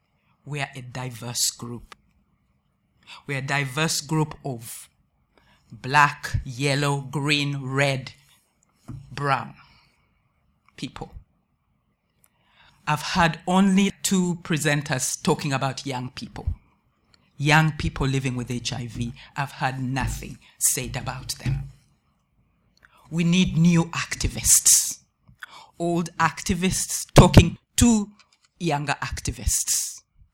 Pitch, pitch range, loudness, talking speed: 140 Hz, 130-160 Hz, -23 LUFS, 90 wpm